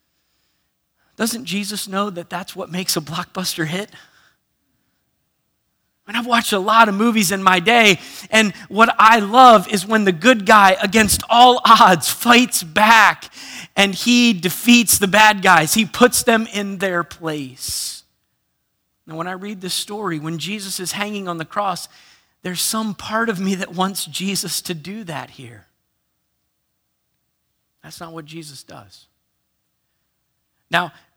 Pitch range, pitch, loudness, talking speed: 160-220 Hz, 190 Hz, -15 LUFS, 160 wpm